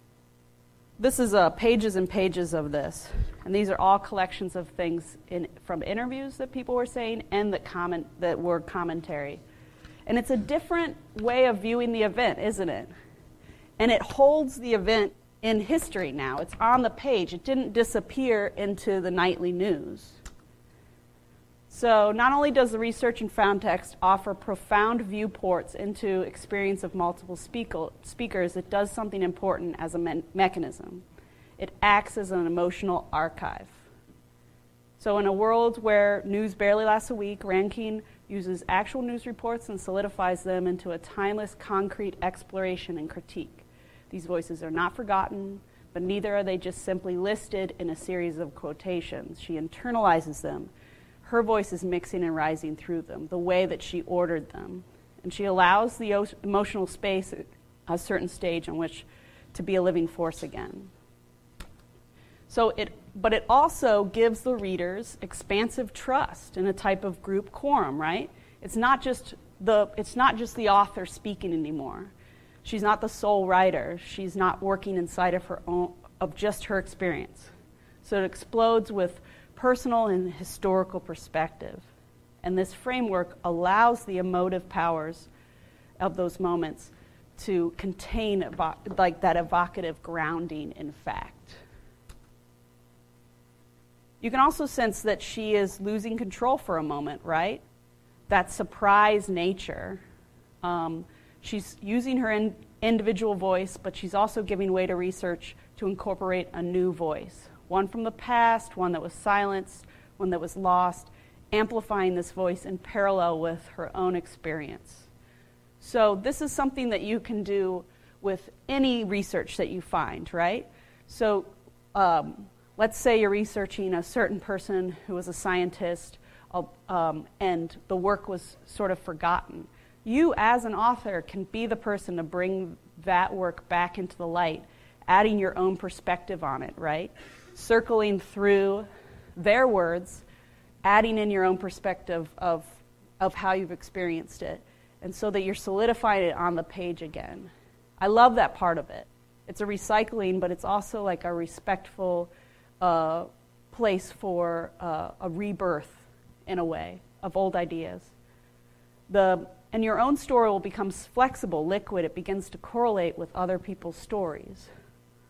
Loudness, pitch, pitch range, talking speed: -27 LUFS, 190 Hz, 170-210 Hz, 155 wpm